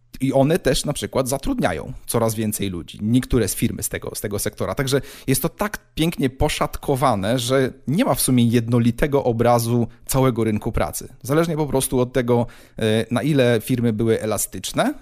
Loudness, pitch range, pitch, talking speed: -21 LUFS, 115-135 Hz, 125 Hz, 170 wpm